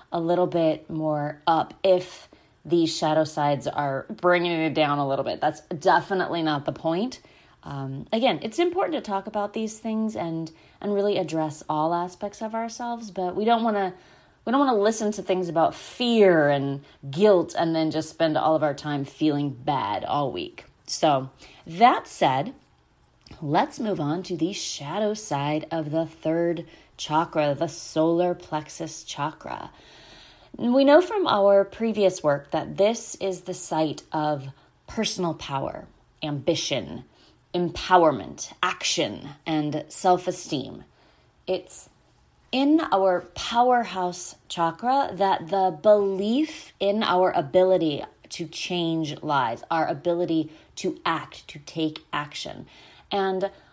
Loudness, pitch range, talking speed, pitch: -25 LUFS, 155-200 Hz, 140 wpm, 175 Hz